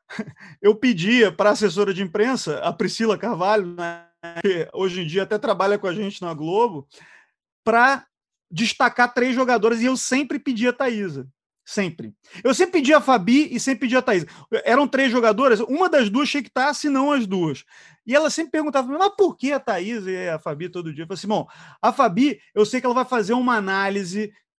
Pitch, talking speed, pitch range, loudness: 230 Hz, 205 wpm, 195-265 Hz, -21 LUFS